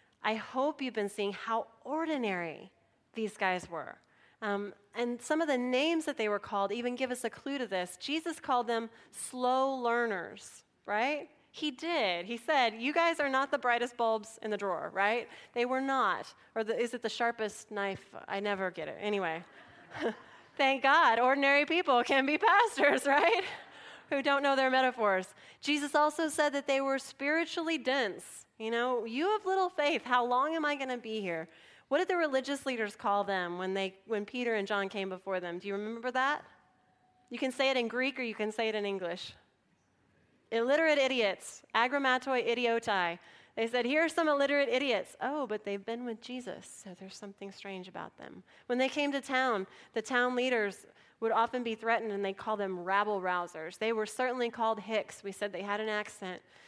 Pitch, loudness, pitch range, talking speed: 235 Hz, -32 LUFS, 205-270 Hz, 195 wpm